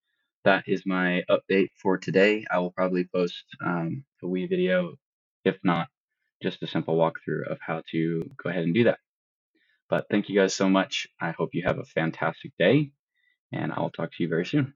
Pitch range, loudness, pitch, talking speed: 90-140 Hz, -26 LUFS, 95 Hz, 195 wpm